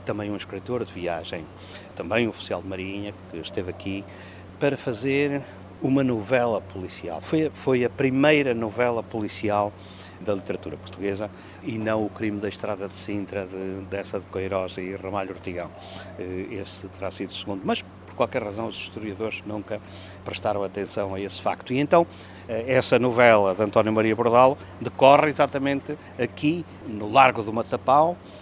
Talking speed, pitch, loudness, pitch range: 155 wpm, 100 Hz, -25 LUFS, 95-120 Hz